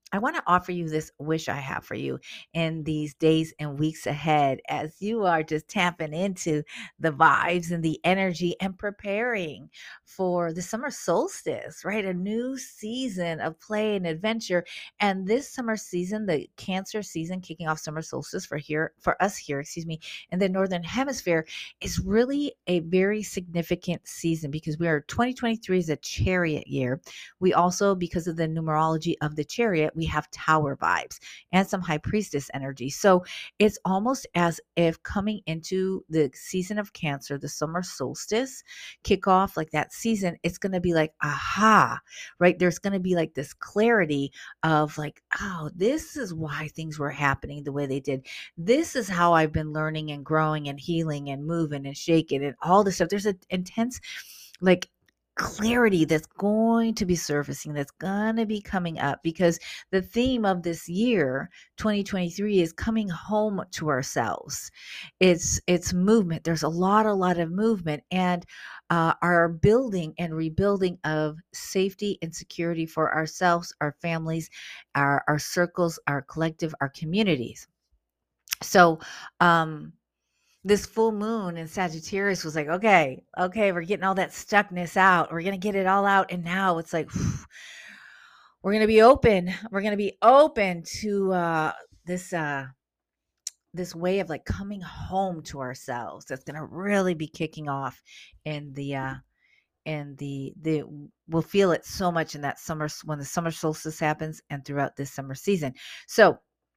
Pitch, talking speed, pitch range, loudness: 170 Hz, 165 wpm, 155-195 Hz, -26 LUFS